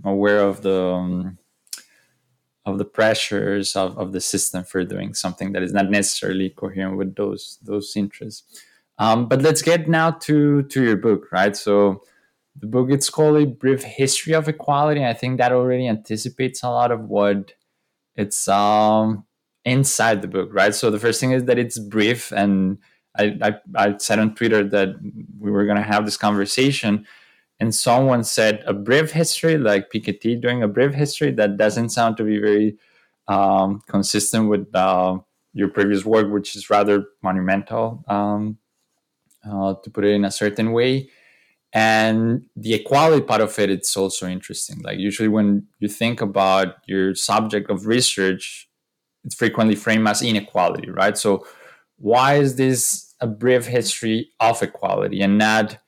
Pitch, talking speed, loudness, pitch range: 105 Hz, 165 wpm, -19 LUFS, 100-120 Hz